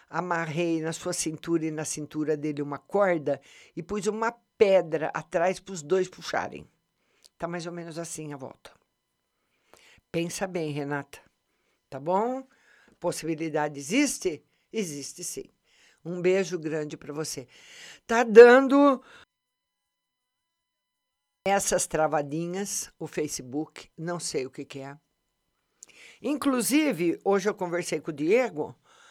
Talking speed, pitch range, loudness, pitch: 120 wpm, 150-195 Hz, -26 LUFS, 170 Hz